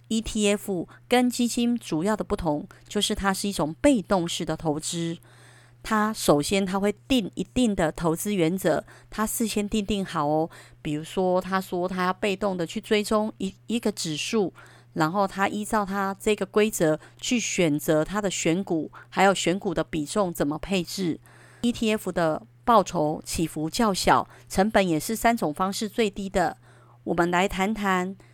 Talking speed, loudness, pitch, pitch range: 245 characters per minute, -25 LUFS, 190 Hz, 160-210 Hz